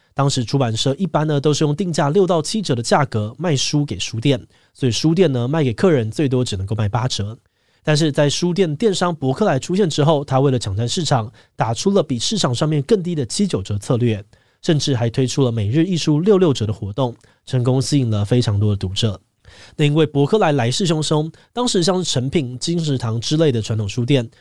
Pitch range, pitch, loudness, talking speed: 115-160 Hz, 140 Hz, -18 LUFS, 325 characters per minute